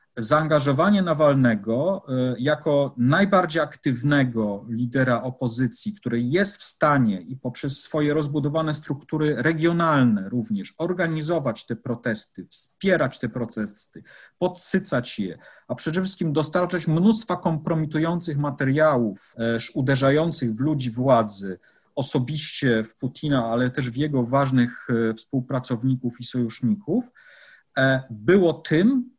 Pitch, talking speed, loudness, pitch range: 140 Hz, 105 wpm, -23 LUFS, 120-160 Hz